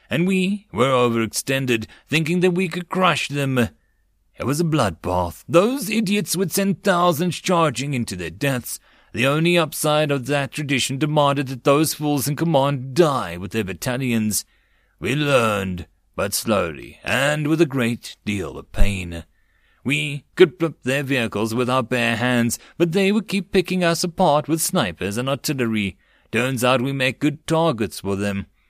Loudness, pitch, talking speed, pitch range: -21 LUFS, 135 Hz, 165 wpm, 115-165 Hz